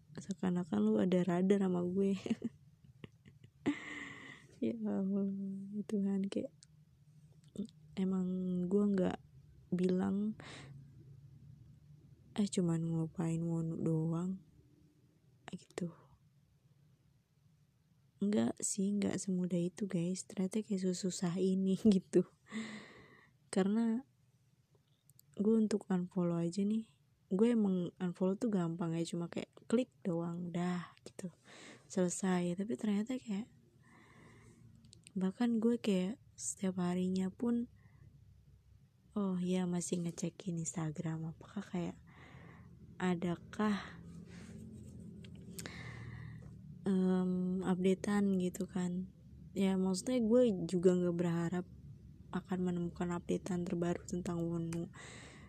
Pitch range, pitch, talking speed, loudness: 155-195 Hz, 180 Hz, 90 wpm, -37 LUFS